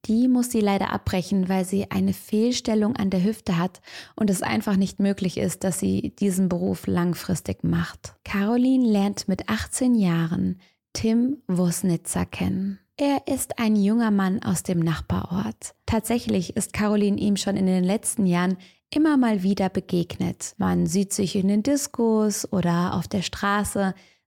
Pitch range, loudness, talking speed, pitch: 180-215 Hz, -24 LUFS, 160 wpm, 195 Hz